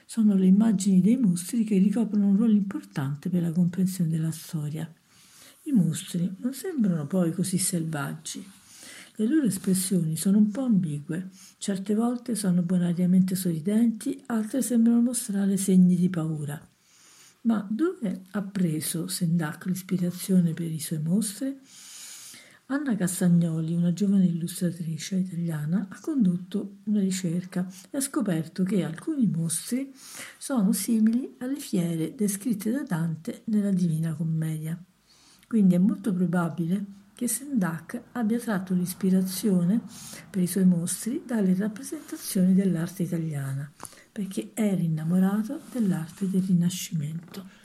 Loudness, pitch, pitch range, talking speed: -26 LUFS, 190 Hz, 175-215 Hz, 125 wpm